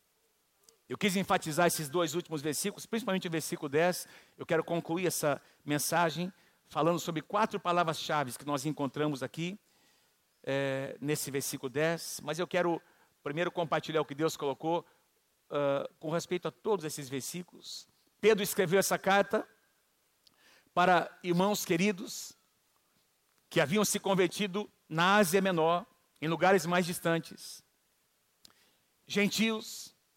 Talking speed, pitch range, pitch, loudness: 125 wpm, 155-195 Hz, 170 Hz, -31 LUFS